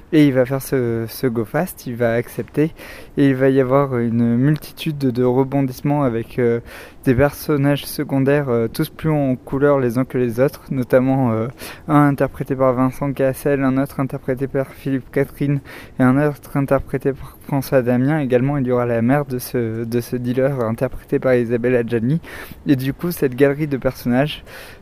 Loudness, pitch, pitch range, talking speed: -19 LUFS, 135 Hz, 125-140 Hz, 185 wpm